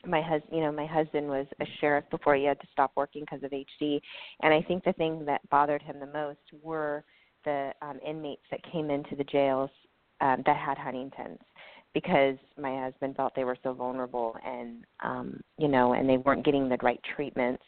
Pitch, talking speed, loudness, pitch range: 140 Hz, 205 wpm, -30 LUFS, 130-150 Hz